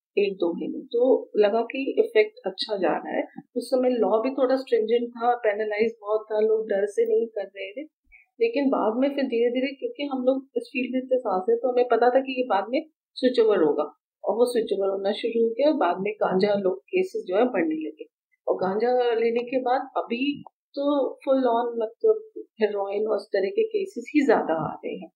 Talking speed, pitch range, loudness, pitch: 220 wpm, 220-300 Hz, -25 LUFS, 250 Hz